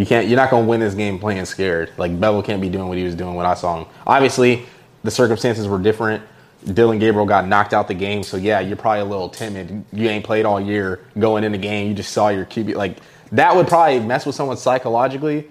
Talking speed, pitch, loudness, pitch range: 250 wpm, 105 Hz, -18 LUFS, 100-120 Hz